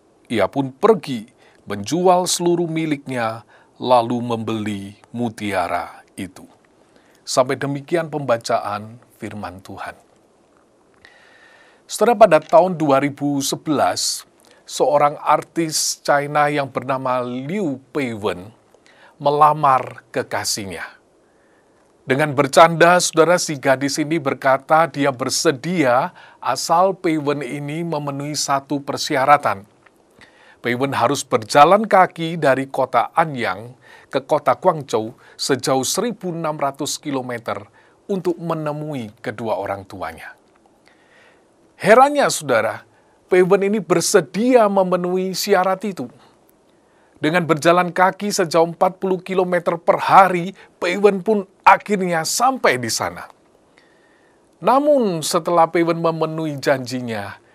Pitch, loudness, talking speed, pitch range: 155 Hz, -18 LUFS, 90 wpm, 130-180 Hz